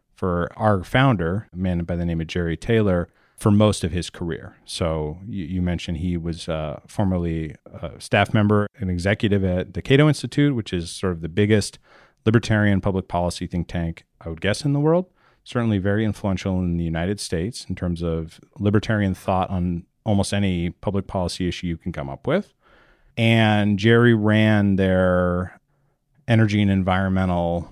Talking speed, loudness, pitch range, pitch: 175 wpm, -22 LUFS, 85-105 Hz, 95 Hz